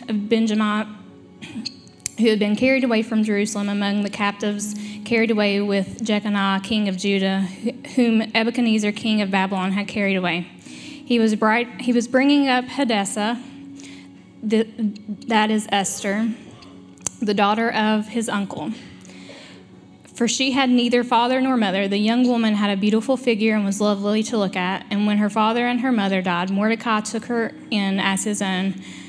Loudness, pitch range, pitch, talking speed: -21 LUFS, 195-230 Hz, 210 Hz, 160 wpm